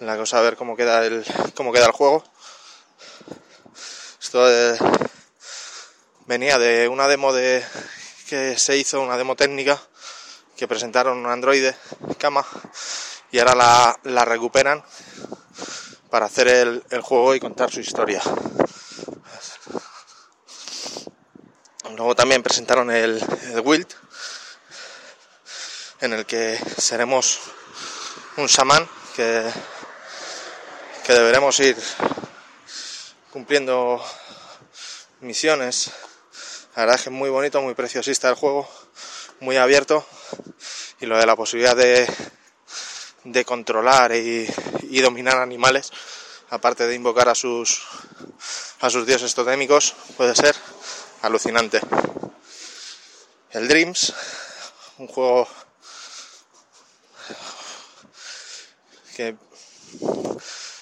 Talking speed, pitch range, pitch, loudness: 100 wpm, 120-140 Hz, 130 Hz, -19 LUFS